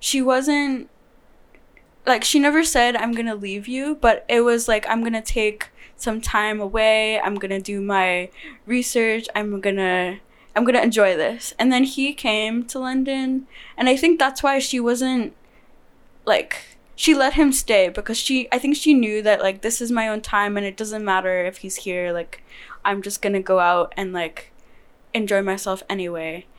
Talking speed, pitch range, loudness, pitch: 195 wpm, 200-255 Hz, -20 LUFS, 220 Hz